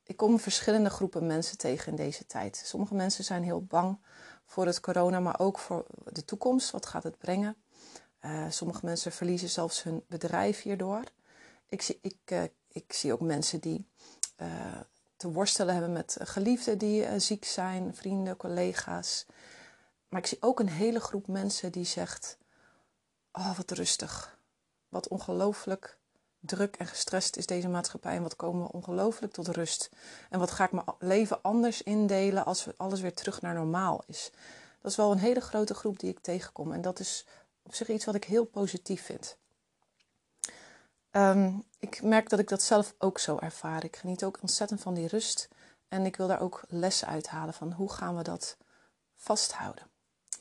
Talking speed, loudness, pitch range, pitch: 180 wpm, -32 LUFS, 175-210 Hz, 190 Hz